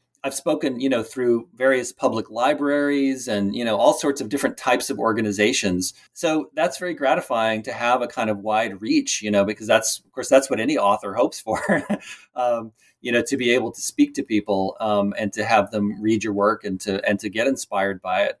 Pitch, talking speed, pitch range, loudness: 110 Hz, 220 wpm, 105-130 Hz, -22 LUFS